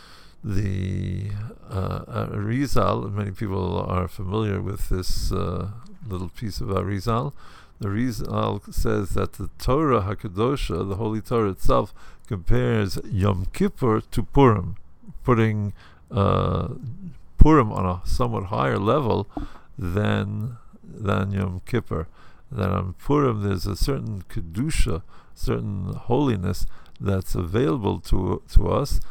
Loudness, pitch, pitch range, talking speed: -25 LUFS, 100 Hz, 95-115 Hz, 115 wpm